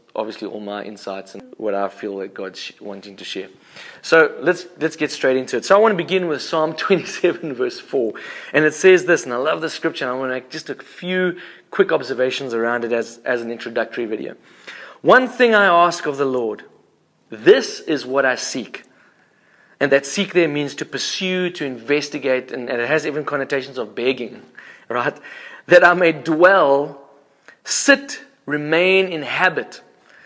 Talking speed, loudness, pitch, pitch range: 185 wpm, -18 LUFS, 150 Hz, 130-180 Hz